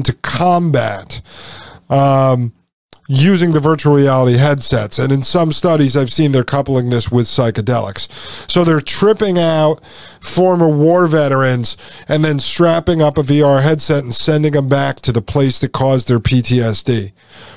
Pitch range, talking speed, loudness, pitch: 125-155 Hz, 150 wpm, -13 LUFS, 140 Hz